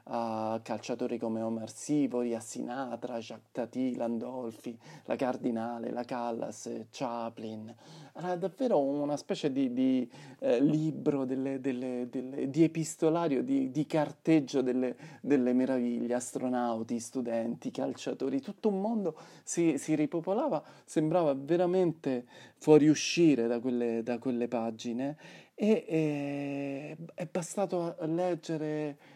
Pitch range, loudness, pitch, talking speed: 120-160 Hz, -32 LUFS, 135 Hz, 120 wpm